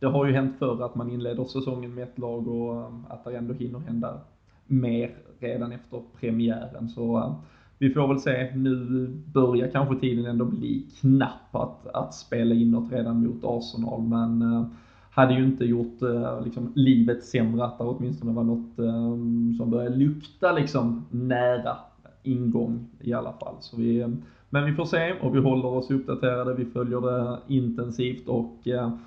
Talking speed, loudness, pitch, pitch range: 165 wpm, -26 LUFS, 120 Hz, 115-130 Hz